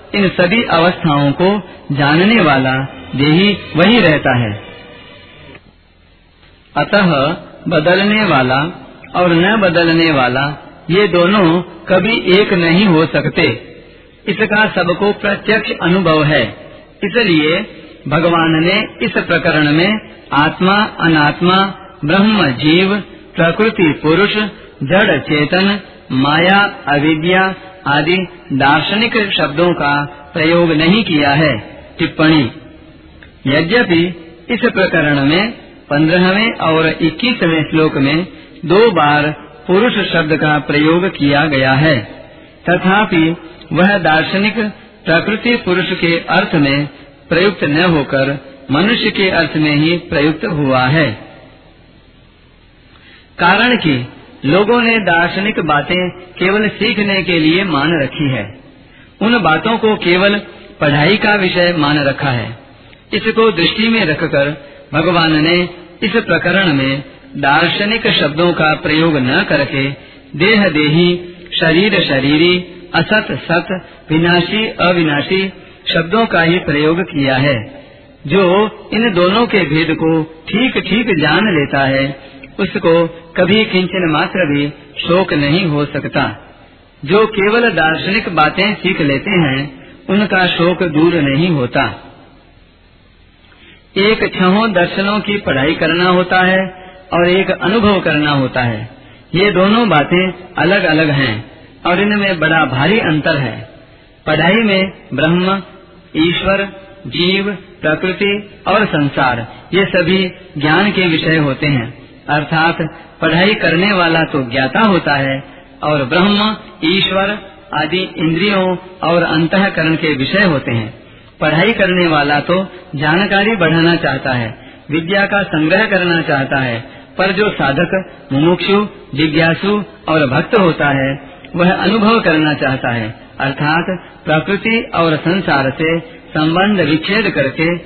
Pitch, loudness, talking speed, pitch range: 170 Hz, -13 LUFS, 120 wpm, 145-190 Hz